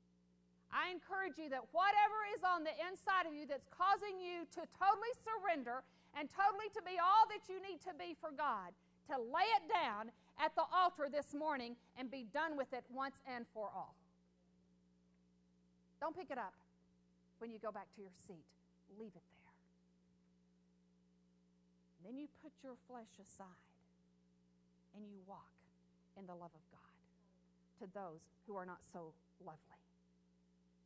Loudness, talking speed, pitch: -41 LUFS, 160 wpm, 200 Hz